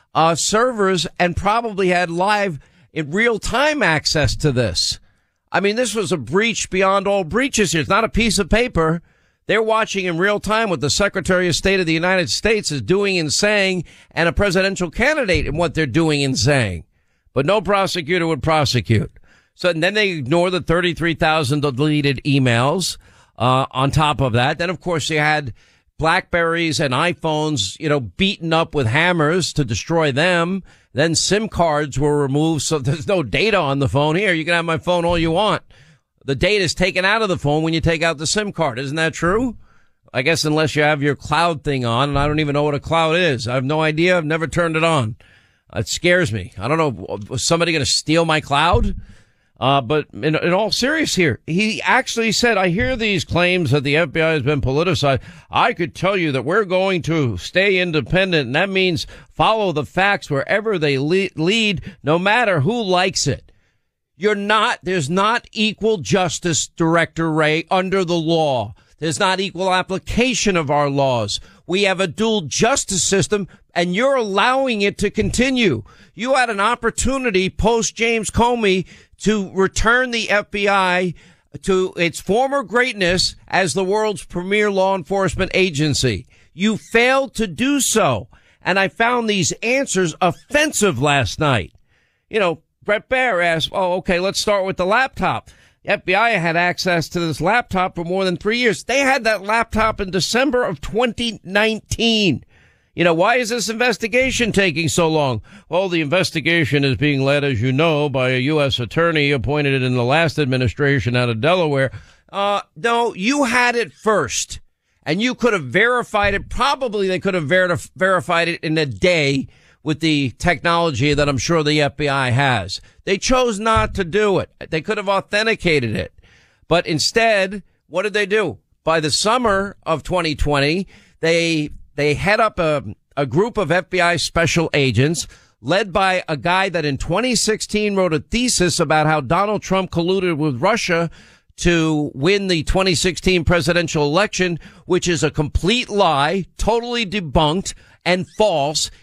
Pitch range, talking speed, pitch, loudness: 150-200 Hz, 175 wpm, 175 Hz, -18 LUFS